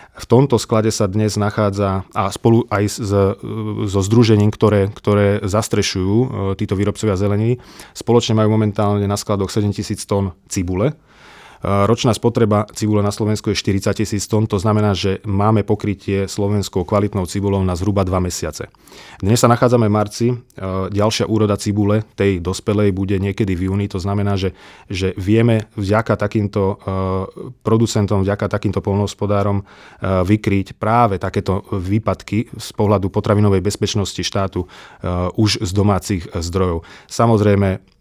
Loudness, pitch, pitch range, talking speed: -18 LUFS, 105 Hz, 100-110 Hz, 135 wpm